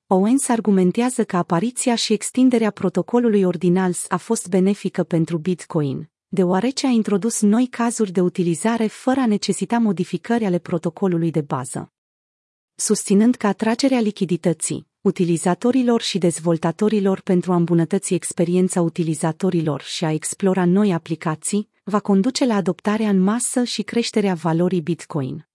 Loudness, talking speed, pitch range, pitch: -20 LUFS, 130 wpm, 175-220 Hz, 190 Hz